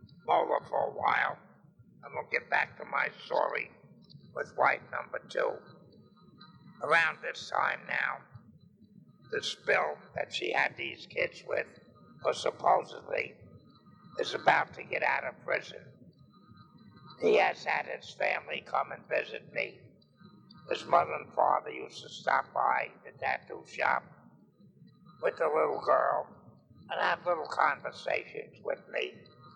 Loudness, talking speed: -32 LUFS, 135 wpm